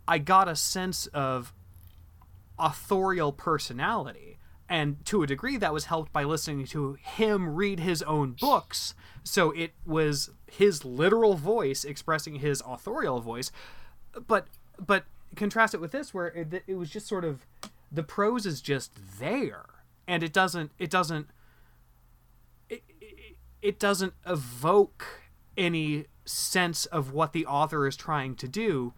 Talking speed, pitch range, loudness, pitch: 145 wpm, 140-190 Hz, -28 LUFS, 160 Hz